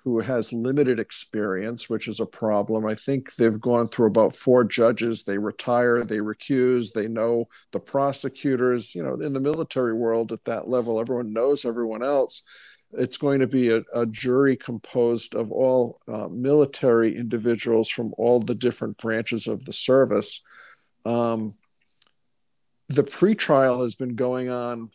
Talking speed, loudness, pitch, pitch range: 155 wpm, -23 LUFS, 120 Hz, 115-130 Hz